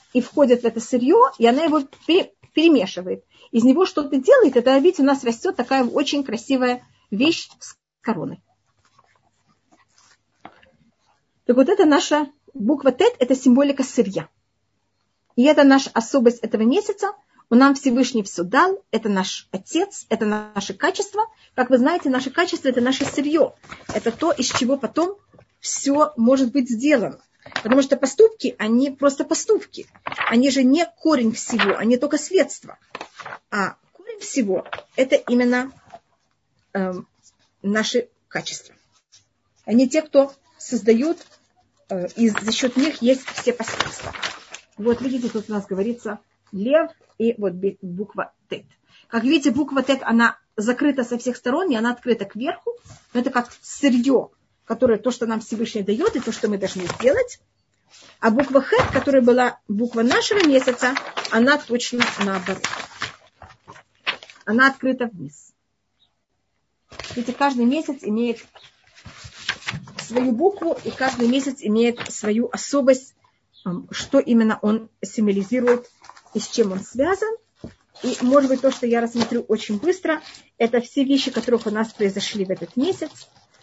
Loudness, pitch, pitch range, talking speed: -20 LUFS, 250 Hz, 225-285 Hz, 140 wpm